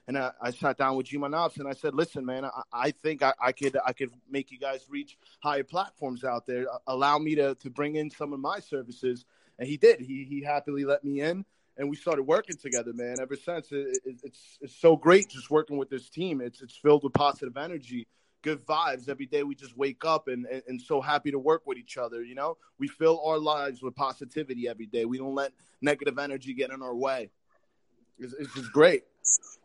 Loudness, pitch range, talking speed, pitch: -29 LUFS, 130-150 Hz, 230 wpm, 140 Hz